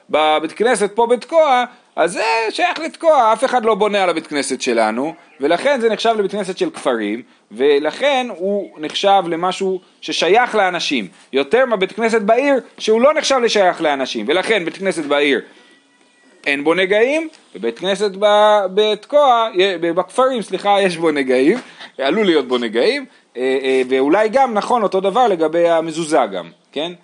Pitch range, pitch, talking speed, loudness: 160-230 Hz, 195 Hz, 155 wpm, -16 LUFS